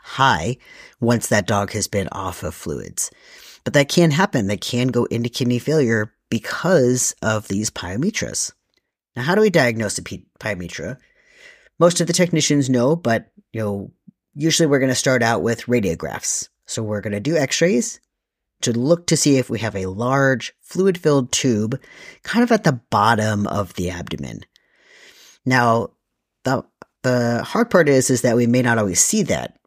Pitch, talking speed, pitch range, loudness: 125 Hz, 175 wpm, 110-165 Hz, -19 LUFS